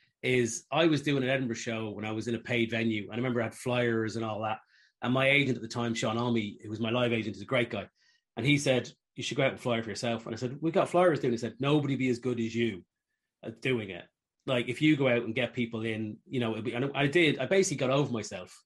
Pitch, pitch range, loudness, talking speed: 120 Hz, 115-135 Hz, -30 LUFS, 290 wpm